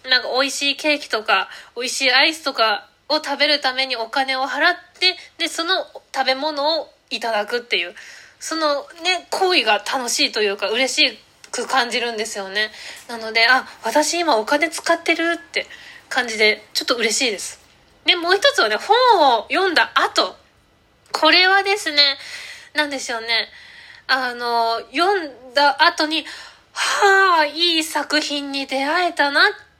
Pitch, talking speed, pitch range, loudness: 295 Hz, 290 characters per minute, 255-345 Hz, -18 LUFS